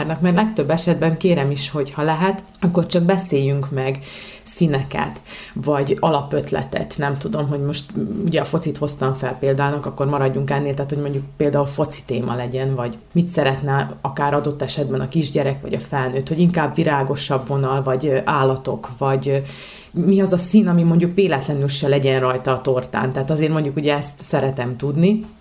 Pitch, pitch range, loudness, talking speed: 145 Hz, 135-165 Hz, -20 LUFS, 170 wpm